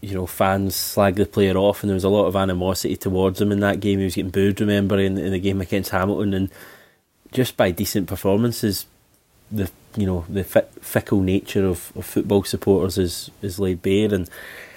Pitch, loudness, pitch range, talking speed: 100 Hz, -21 LUFS, 95-100 Hz, 200 wpm